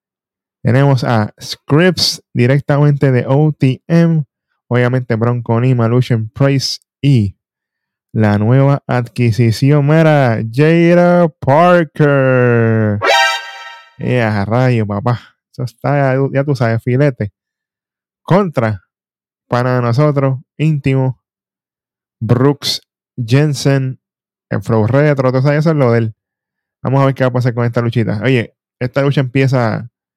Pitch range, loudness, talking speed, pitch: 120-140 Hz, -13 LUFS, 110 wpm, 130 Hz